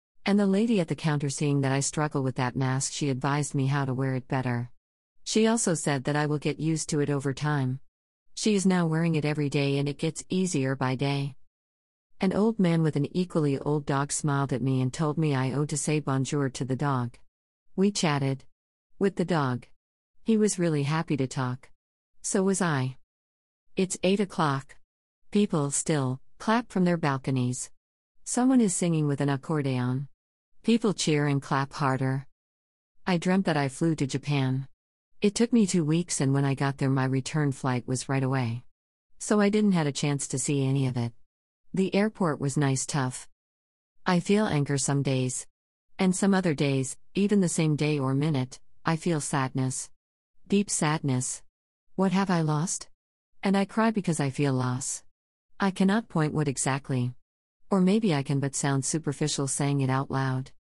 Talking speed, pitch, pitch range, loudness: 185 wpm, 140 Hz, 130-165 Hz, -27 LUFS